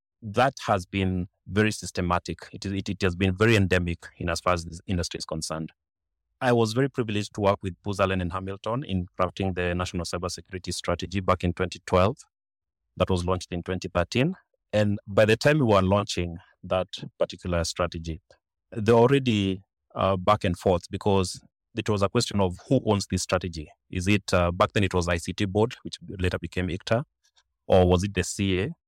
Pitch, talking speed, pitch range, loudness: 95 Hz, 185 wpm, 90-105 Hz, -26 LUFS